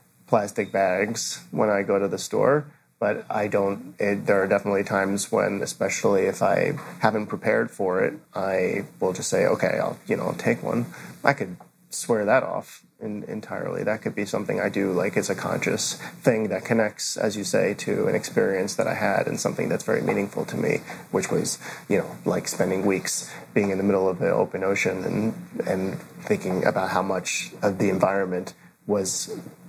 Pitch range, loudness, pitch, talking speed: 95-100 Hz, -25 LUFS, 100 Hz, 195 wpm